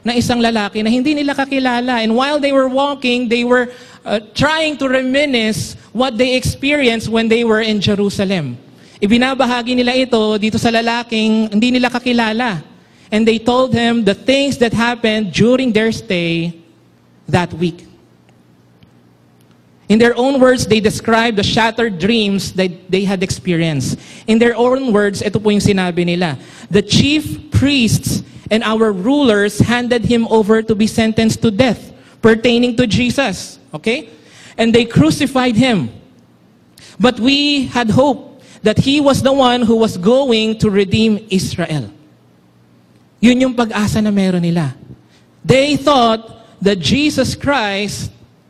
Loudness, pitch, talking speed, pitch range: -14 LUFS, 225 Hz, 145 wpm, 200-250 Hz